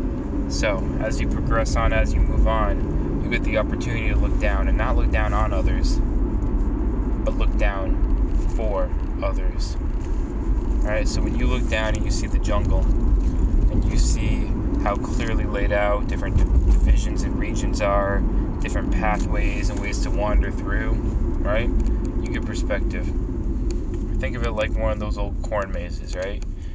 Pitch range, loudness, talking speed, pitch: 75-105 Hz, -24 LUFS, 165 wpm, 95 Hz